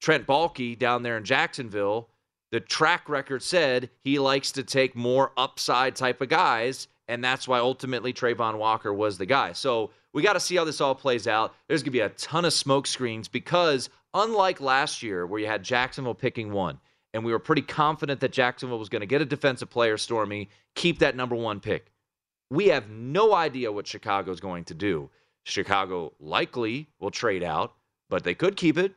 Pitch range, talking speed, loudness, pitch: 115-140 Hz, 200 wpm, -26 LUFS, 125 Hz